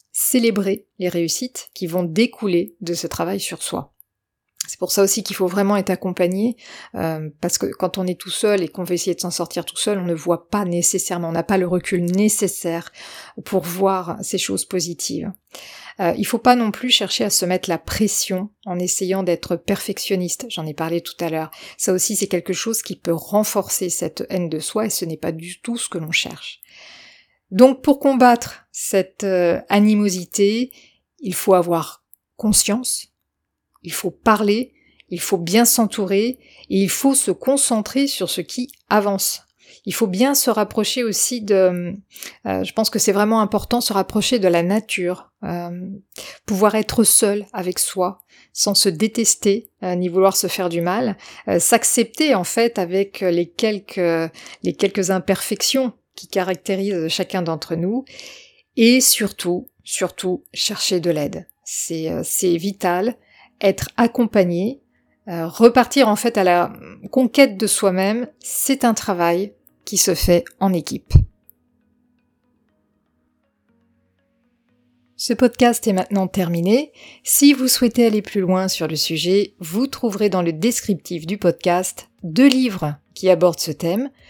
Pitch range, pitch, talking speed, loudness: 180-225 Hz, 195 Hz, 165 wpm, -19 LUFS